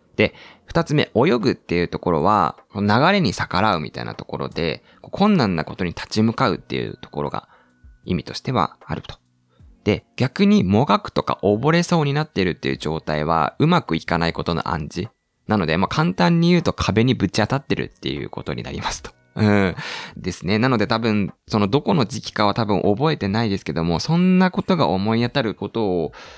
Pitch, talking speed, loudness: 105 Hz, 380 characters per minute, -20 LUFS